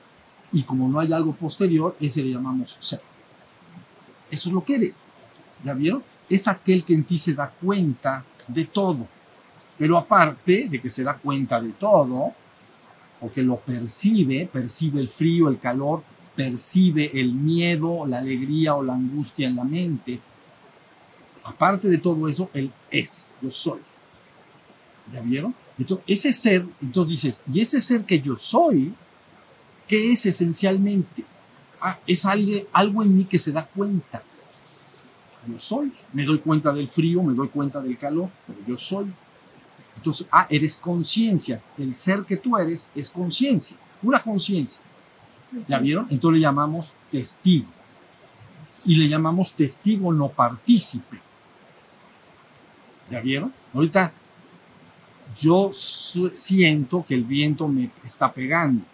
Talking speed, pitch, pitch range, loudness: 145 wpm, 160 Hz, 135-185 Hz, -21 LUFS